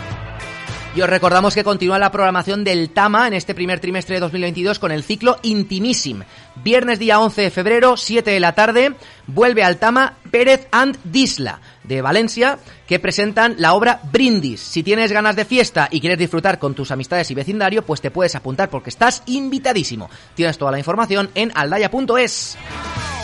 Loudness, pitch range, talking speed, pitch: -16 LUFS, 165-225 Hz, 175 wpm, 195 Hz